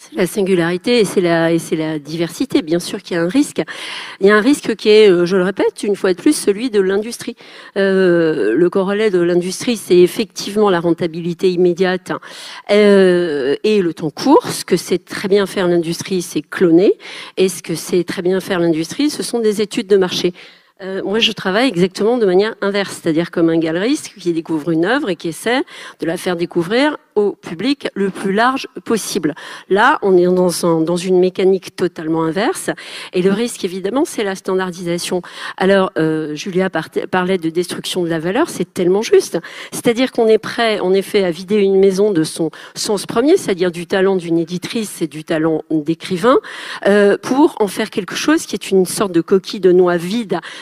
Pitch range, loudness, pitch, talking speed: 175-215 Hz, -16 LUFS, 190 Hz, 200 wpm